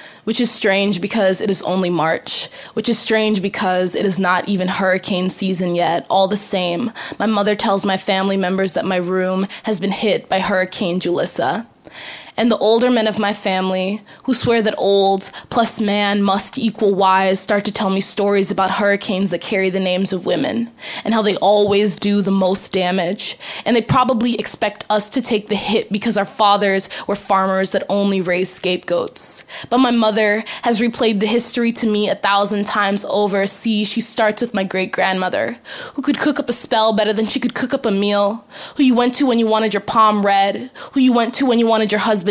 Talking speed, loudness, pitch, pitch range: 205 wpm, -16 LUFS, 205 Hz, 195-225 Hz